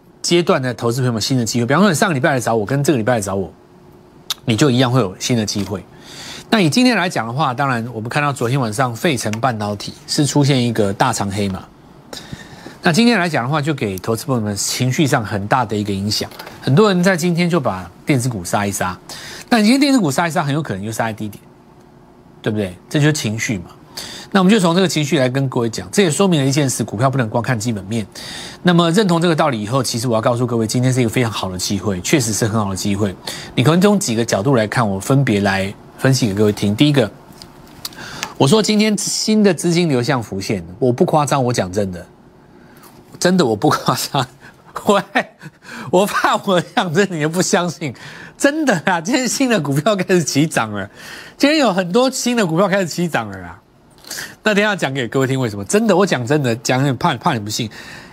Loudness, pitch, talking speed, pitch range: -17 LUFS, 135 Hz, 330 characters per minute, 115-175 Hz